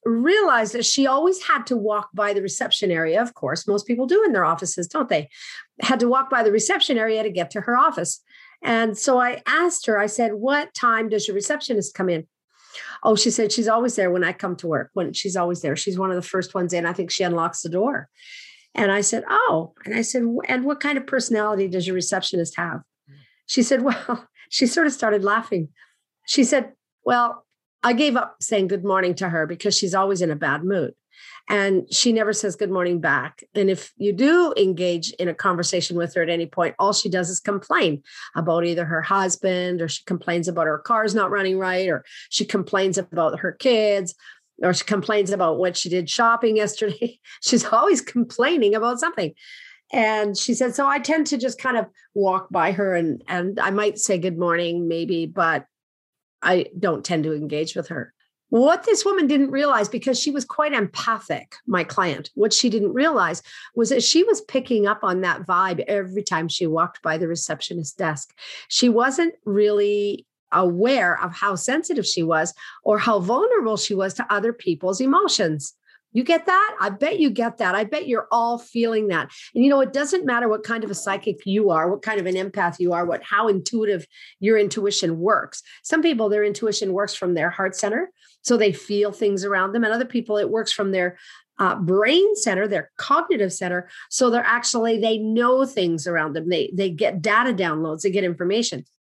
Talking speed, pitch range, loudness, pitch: 205 wpm, 180-240 Hz, -21 LUFS, 205 Hz